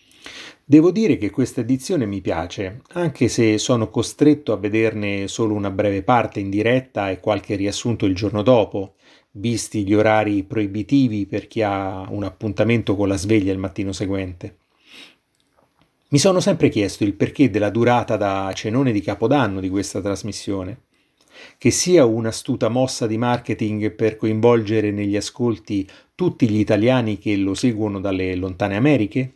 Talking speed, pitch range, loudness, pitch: 150 wpm, 100-120 Hz, -20 LUFS, 110 Hz